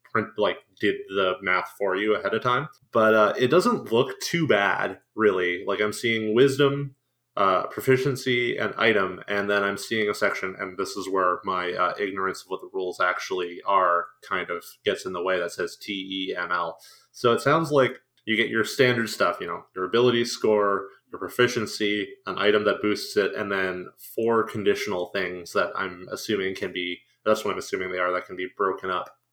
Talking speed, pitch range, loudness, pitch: 200 wpm, 95-120 Hz, -25 LUFS, 105 Hz